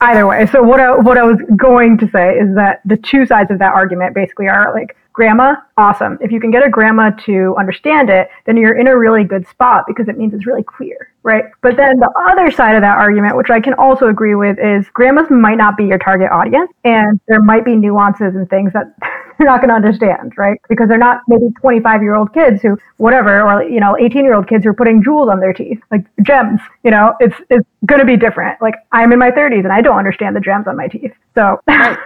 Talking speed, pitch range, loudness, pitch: 245 wpm, 205-250 Hz, -10 LUFS, 220 Hz